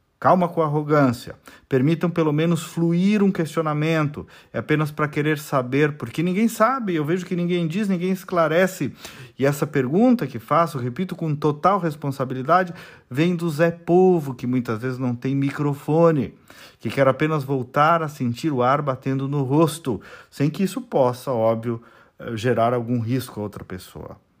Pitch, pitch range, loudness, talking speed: 150 Hz, 130-170 Hz, -21 LUFS, 160 wpm